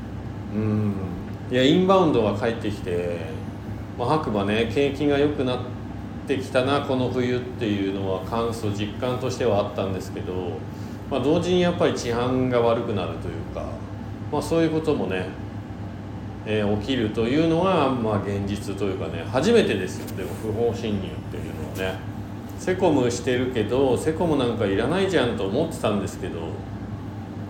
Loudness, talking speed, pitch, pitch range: -24 LUFS, 340 characters per minute, 105 Hz, 100-125 Hz